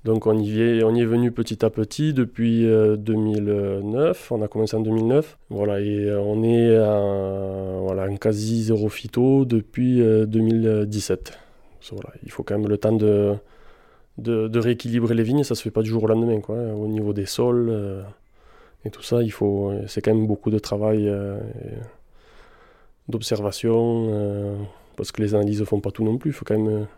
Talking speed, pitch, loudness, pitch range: 195 wpm, 110 Hz, -22 LUFS, 105-115 Hz